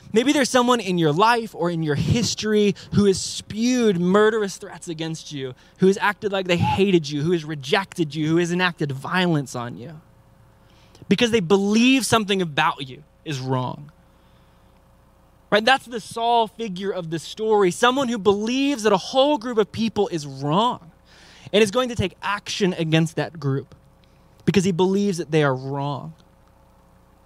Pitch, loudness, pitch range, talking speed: 185 Hz, -21 LUFS, 155-215 Hz, 170 wpm